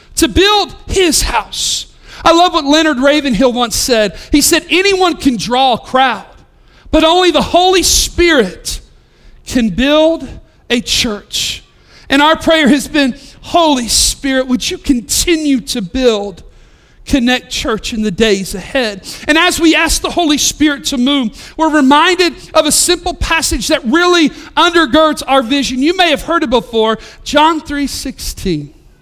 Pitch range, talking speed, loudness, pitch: 255-330 Hz, 155 wpm, -11 LUFS, 290 Hz